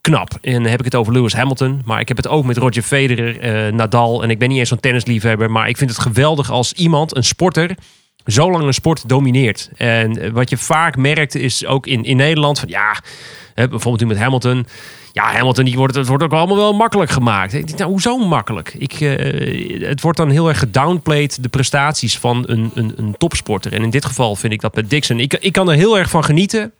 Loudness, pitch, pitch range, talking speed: -15 LUFS, 130 Hz, 120-150 Hz, 235 wpm